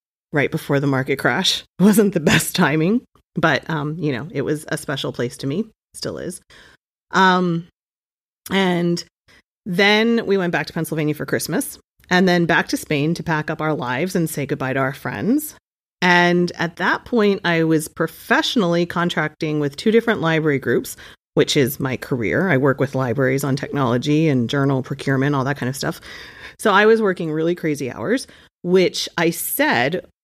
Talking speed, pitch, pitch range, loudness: 180 wpm, 165 Hz, 145-180 Hz, -19 LUFS